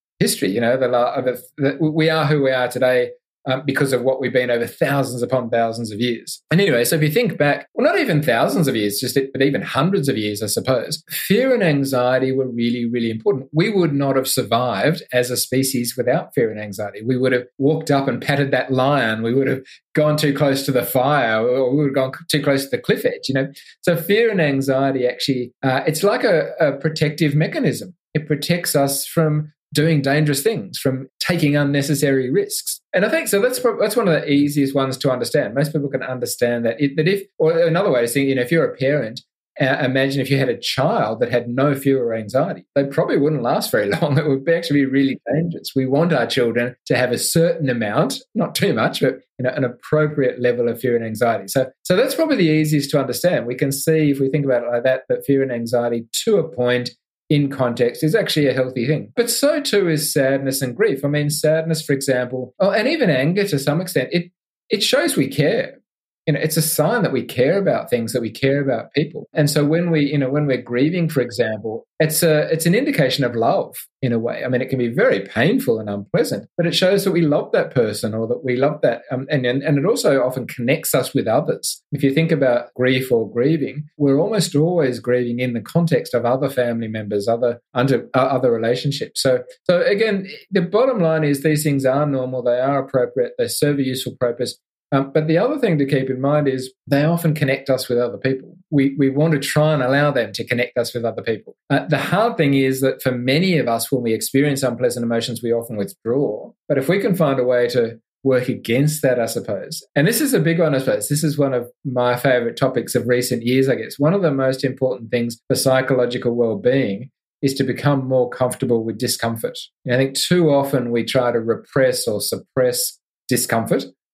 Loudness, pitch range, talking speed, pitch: -19 LUFS, 125-155 Hz, 230 wpm, 135 Hz